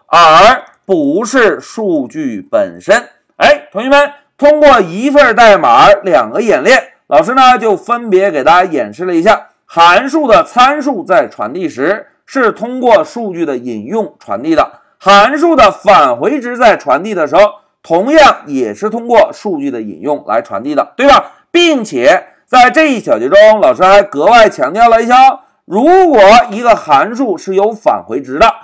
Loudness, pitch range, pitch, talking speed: -9 LUFS, 210-305 Hz, 265 Hz, 240 characters per minute